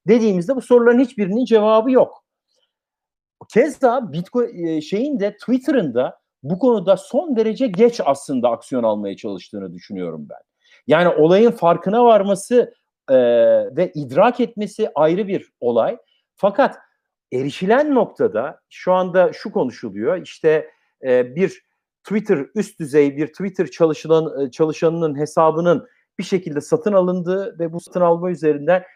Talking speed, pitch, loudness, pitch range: 125 wpm, 190 Hz, -18 LUFS, 160-240 Hz